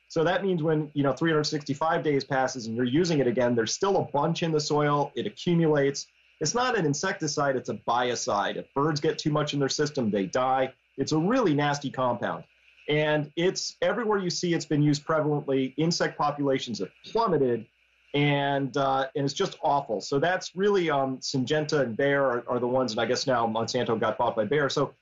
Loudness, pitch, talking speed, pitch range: -26 LUFS, 145 Hz, 205 wpm, 135-160 Hz